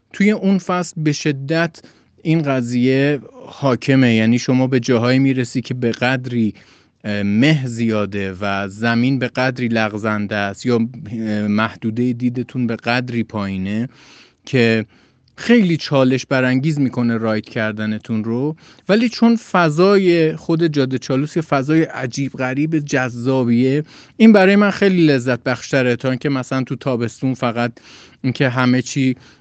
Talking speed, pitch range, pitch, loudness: 130 wpm, 115-145 Hz, 130 Hz, -17 LUFS